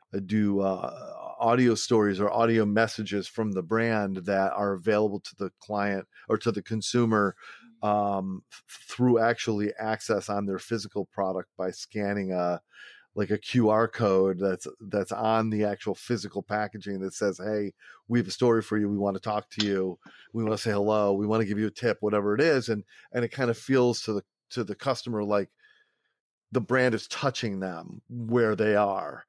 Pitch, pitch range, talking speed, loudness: 105 Hz, 100-115 Hz, 195 wpm, -27 LUFS